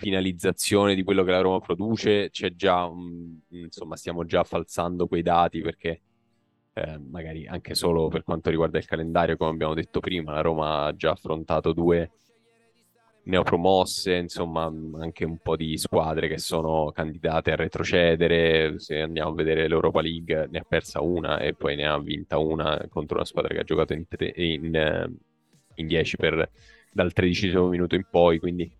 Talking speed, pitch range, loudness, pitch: 165 wpm, 80-90 Hz, -25 LUFS, 85 Hz